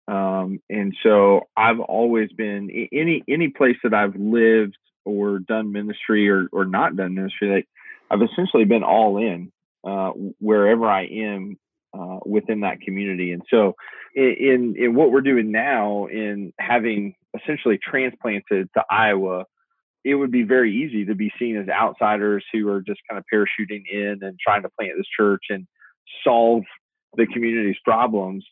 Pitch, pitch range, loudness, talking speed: 105 Hz, 100-115 Hz, -20 LUFS, 160 wpm